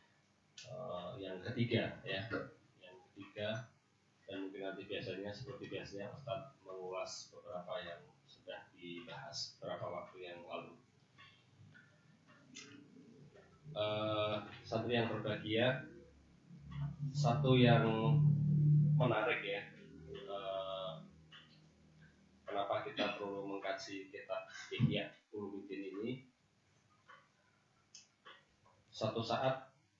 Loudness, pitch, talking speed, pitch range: -39 LUFS, 110 Hz, 80 wpm, 100-130 Hz